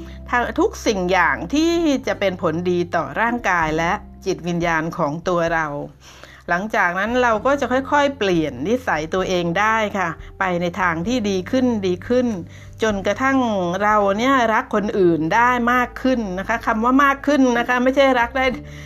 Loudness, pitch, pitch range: -19 LUFS, 205 Hz, 175-245 Hz